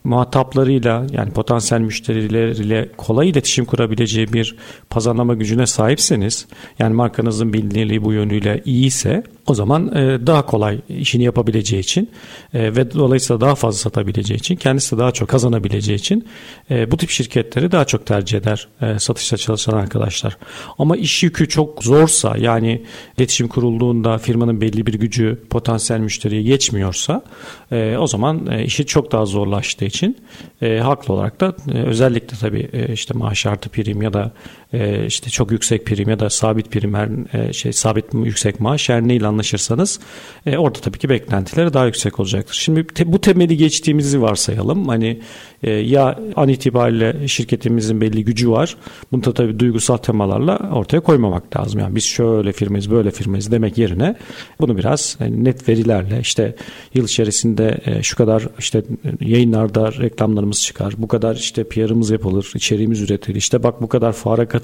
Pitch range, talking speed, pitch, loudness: 110-135 Hz, 150 wpm, 115 Hz, -17 LUFS